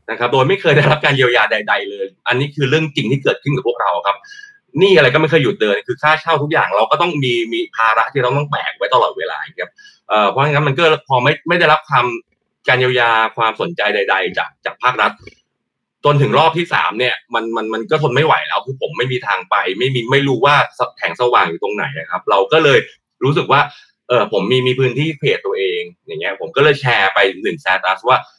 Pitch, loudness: 155 Hz, -15 LUFS